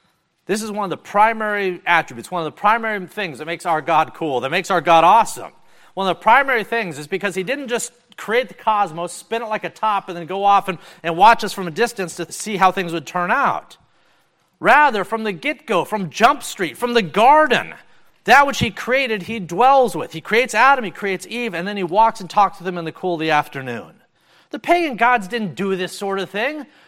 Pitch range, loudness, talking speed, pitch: 175-230 Hz, -18 LUFS, 235 wpm, 200 Hz